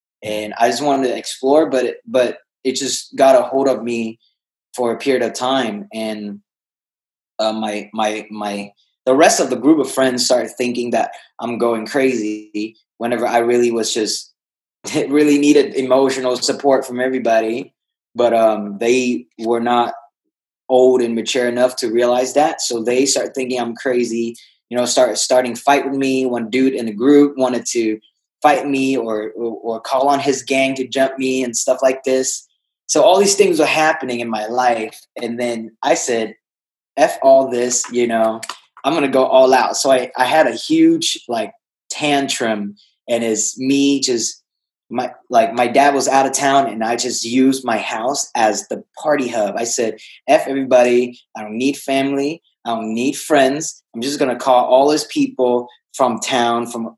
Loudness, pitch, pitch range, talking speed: -17 LUFS, 125 Hz, 115-135 Hz, 180 wpm